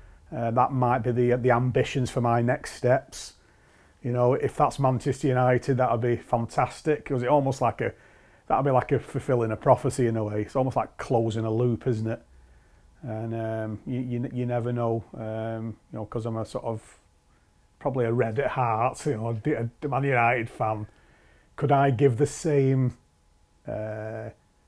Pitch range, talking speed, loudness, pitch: 110-130 Hz, 190 wpm, -26 LUFS, 120 Hz